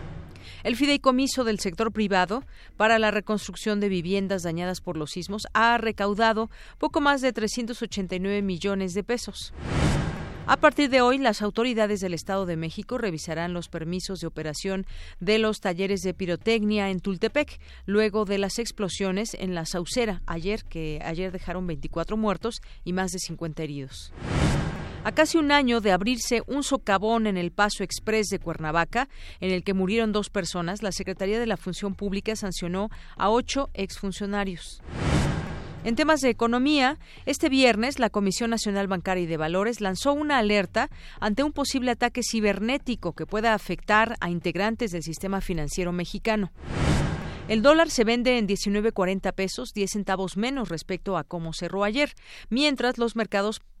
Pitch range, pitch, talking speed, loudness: 185-230 Hz, 205 Hz, 155 wpm, -26 LUFS